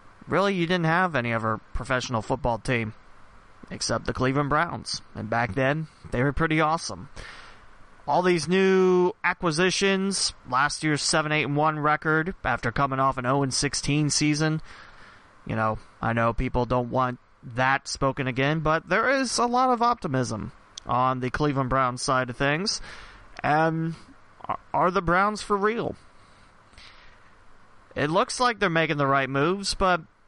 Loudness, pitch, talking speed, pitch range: -25 LUFS, 145 Hz, 155 wpm, 125-175 Hz